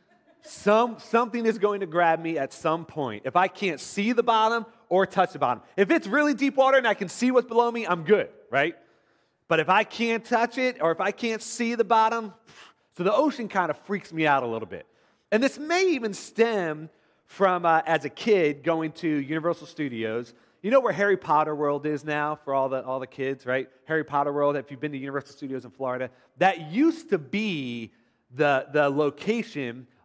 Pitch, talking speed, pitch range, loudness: 175 Hz, 210 wpm, 145-230 Hz, -25 LUFS